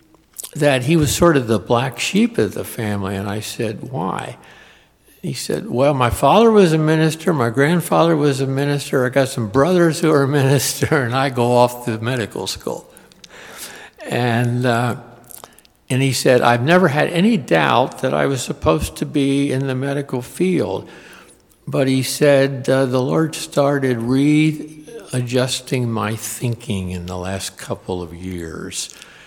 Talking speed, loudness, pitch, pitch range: 160 wpm, -18 LUFS, 130 Hz, 120-145 Hz